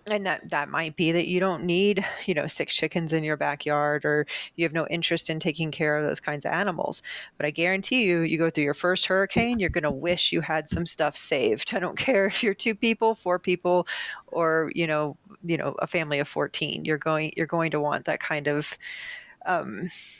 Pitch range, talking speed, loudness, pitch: 155-190 Hz, 225 wpm, -25 LUFS, 170 Hz